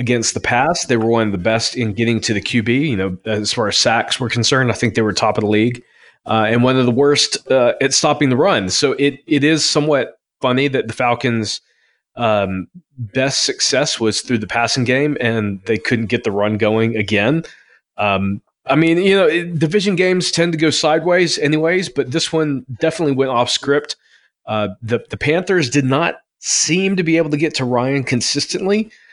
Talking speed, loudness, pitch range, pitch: 210 wpm, -16 LUFS, 115-155 Hz, 130 Hz